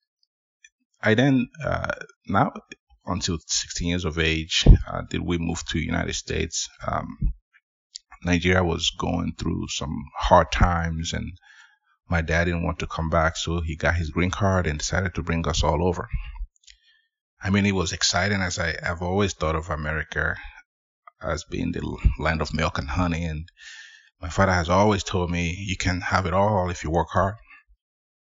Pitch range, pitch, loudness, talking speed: 80-95 Hz, 85 Hz, -24 LUFS, 170 wpm